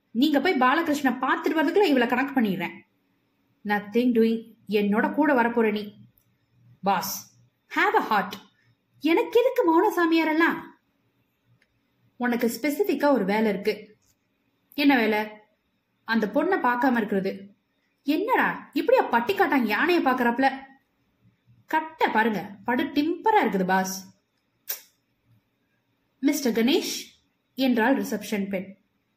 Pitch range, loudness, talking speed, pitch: 215-310 Hz, -24 LUFS, 105 wpm, 250 Hz